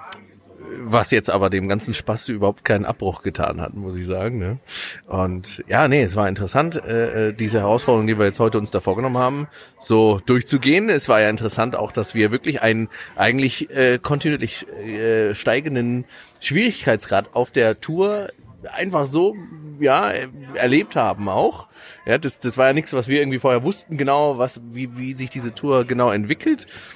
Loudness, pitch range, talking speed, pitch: -20 LUFS, 105-135 Hz, 175 wpm, 120 Hz